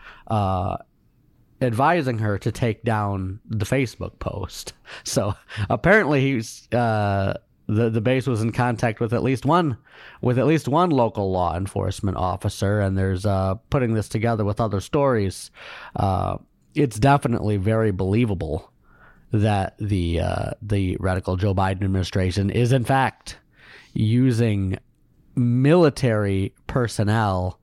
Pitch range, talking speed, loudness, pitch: 95-125 Hz, 130 wpm, -22 LUFS, 110 Hz